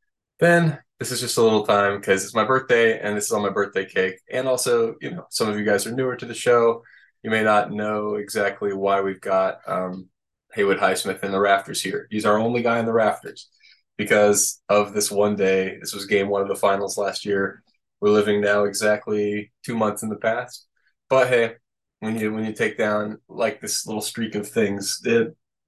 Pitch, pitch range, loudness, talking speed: 105 Hz, 100-115 Hz, -22 LUFS, 215 wpm